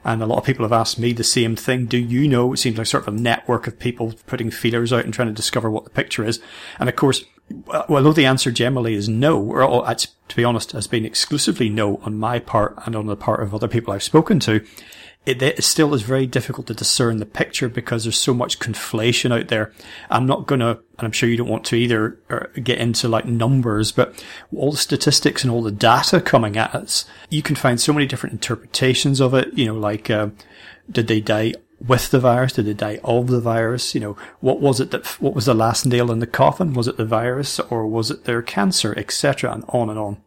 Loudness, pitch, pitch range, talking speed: -19 LUFS, 120 Hz, 110-130 Hz, 240 wpm